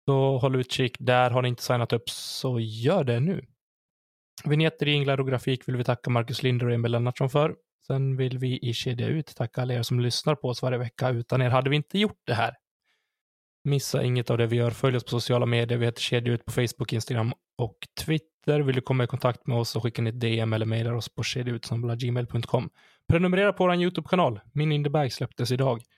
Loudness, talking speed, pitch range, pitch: -26 LUFS, 215 wpm, 120-140 Hz, 125 Hz